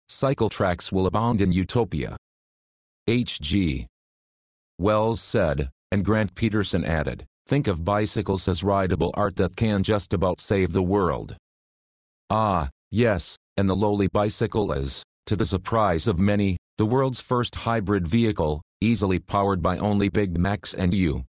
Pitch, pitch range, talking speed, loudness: 100 Hz, 90-110 Hz, 145 wpm, -24 LUFS